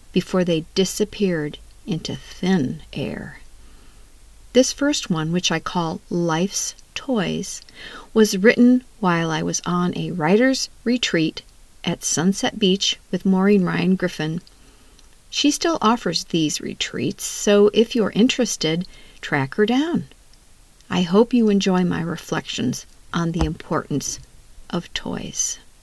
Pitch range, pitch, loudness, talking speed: 170-220 Hz, 190 Hz, -21 LUFS, 125 wpm